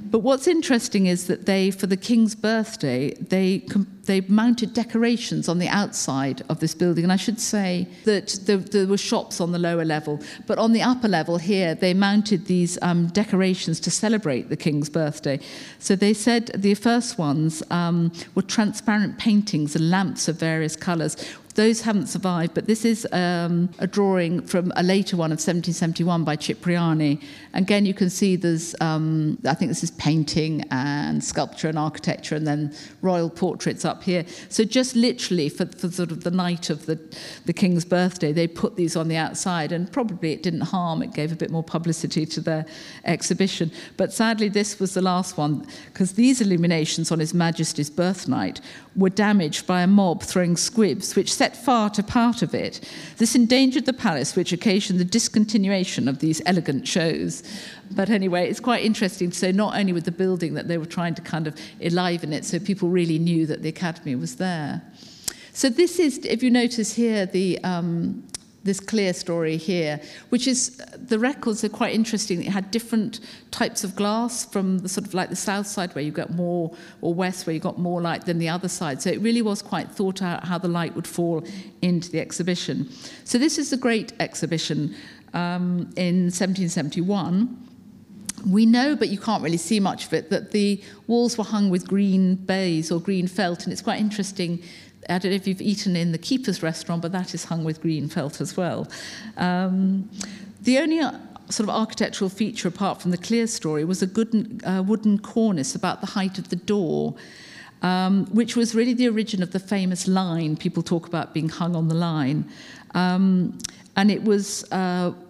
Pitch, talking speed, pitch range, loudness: 185 Hz, 195 wpm, 170-210 Hz, -23 LUFS